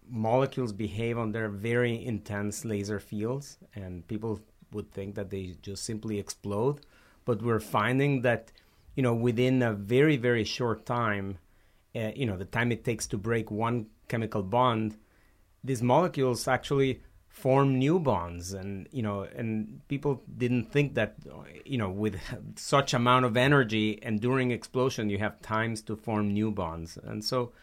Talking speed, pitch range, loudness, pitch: 160 wpm, 105-125 Hz, -29 LUFS, 115 Hz